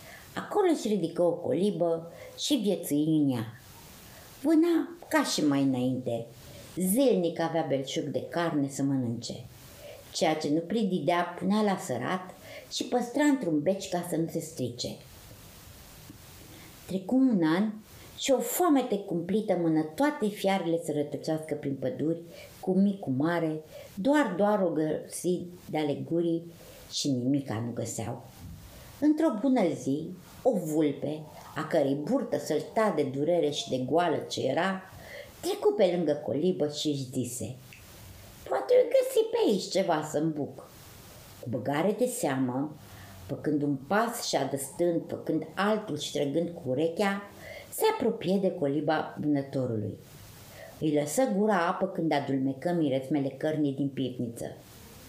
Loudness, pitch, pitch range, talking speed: -29 LUFS, 160 Hz, 140-195 Hz, 135 wpm